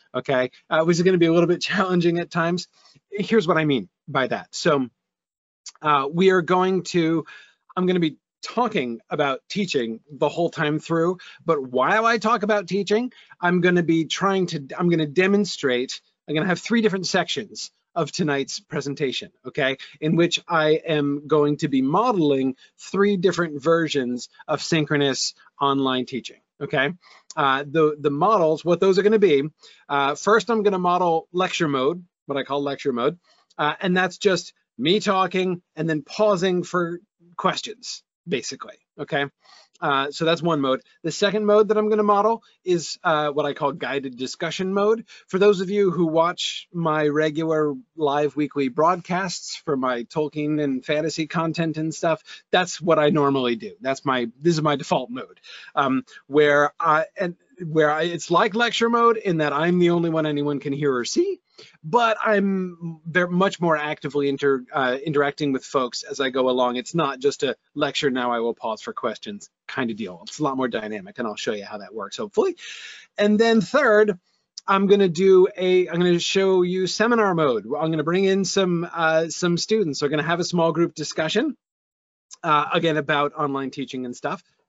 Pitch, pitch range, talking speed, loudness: 165 Hz, 145-190 Hz, 190 wpm, -22 LUFS